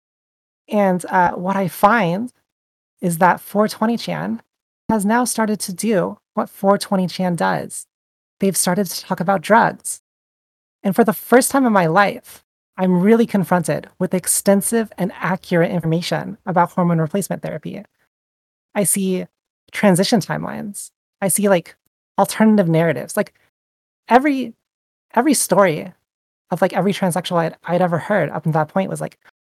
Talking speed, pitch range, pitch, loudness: 145 wpm, 175-210 Hz, 195 Hz, -18 LUFS